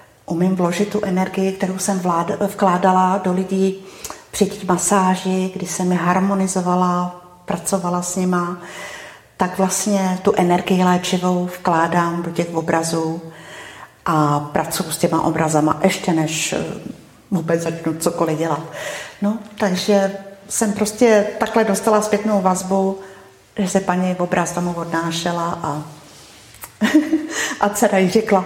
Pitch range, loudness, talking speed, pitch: 170-195 Hz, -19 LUFS, 120 wpm, 185 Hz